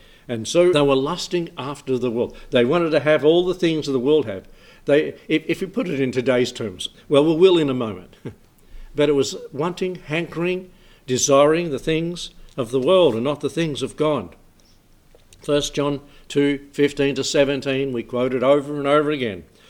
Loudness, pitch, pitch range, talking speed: -20 LUFS, 145 Hz, 130-160 Hz, 190 wpm